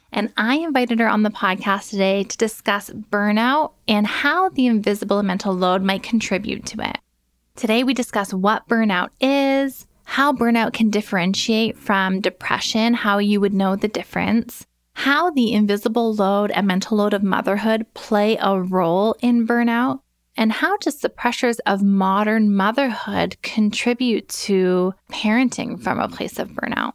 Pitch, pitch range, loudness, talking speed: 215 Hz, 200-240 Hz, -19 LUFS, 155 wpm